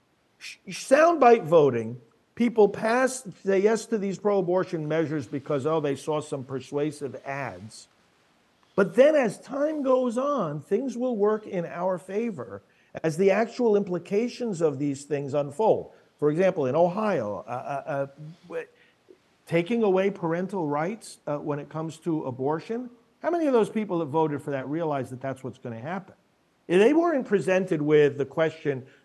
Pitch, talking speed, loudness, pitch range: 180 Hz, 160 wpm, -25 LUFS, 145-225 Hz